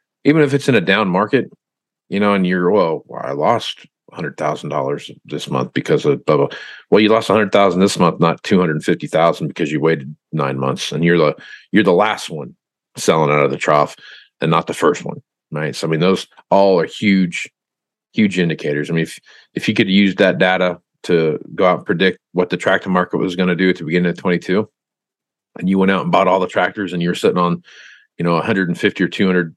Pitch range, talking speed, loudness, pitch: 85-100 Hz, 235 wpm, -16 LUFS, 90 Hz